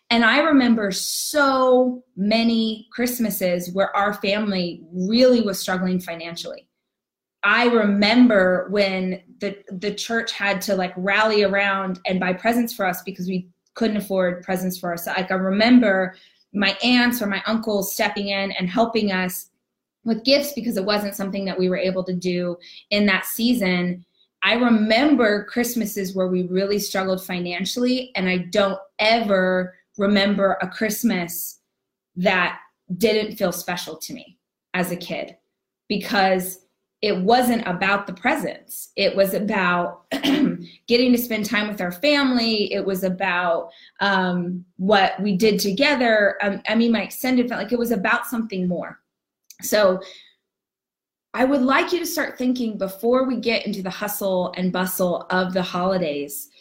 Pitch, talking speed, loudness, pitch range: 200 Hz, 150 wpm, -21 LUFS, 185-230 Hz